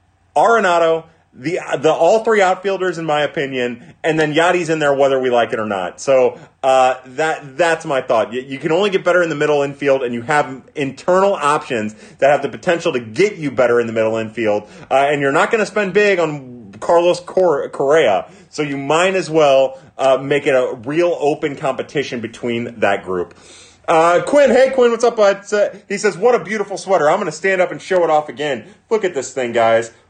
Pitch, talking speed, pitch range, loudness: 150 Hz, 215 wpm, 130-180 Hz, -16 LUFS